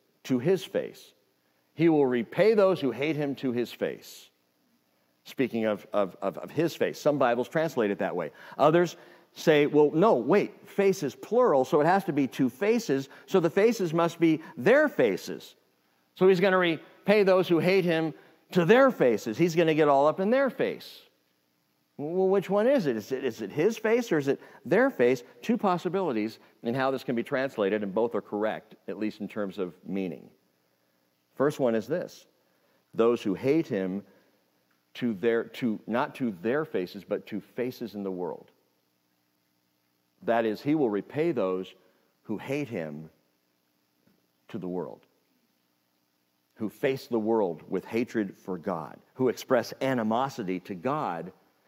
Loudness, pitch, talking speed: -27 LUFS, 120 Hz, 170 wpm